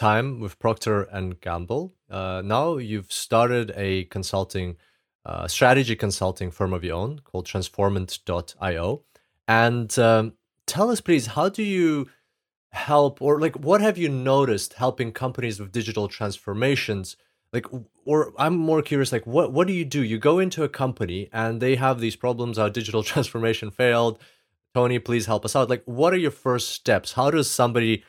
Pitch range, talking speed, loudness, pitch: 105-140 Hz, 170 wpm, -23 LUFS, 120 Hz